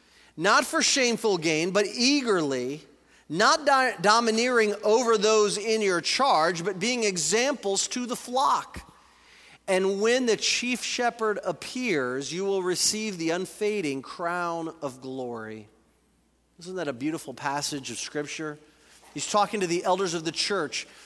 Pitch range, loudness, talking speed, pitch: 155-225 Hz, -25 LUFS, 140 wpm, 195 Hz